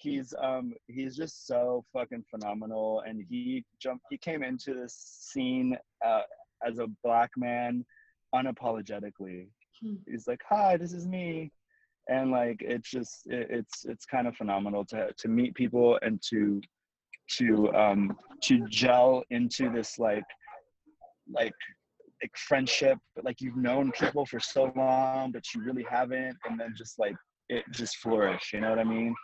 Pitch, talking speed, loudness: 130 Hz, 155 wpm, -30 LUFS